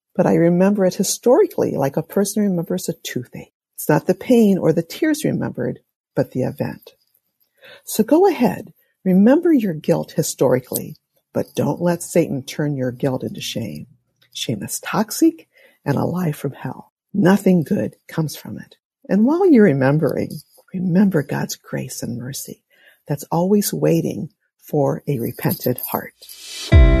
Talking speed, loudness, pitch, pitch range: 150 wpm, -19 LUFS, 185 Hz, 160-220 Hz